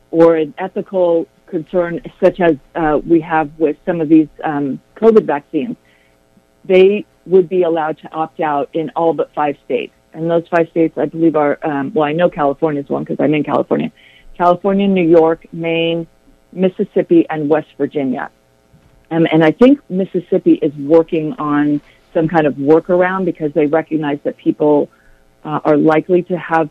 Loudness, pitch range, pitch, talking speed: -15 LUFS, 150-175 Hz, 160 Hz, 170 wpm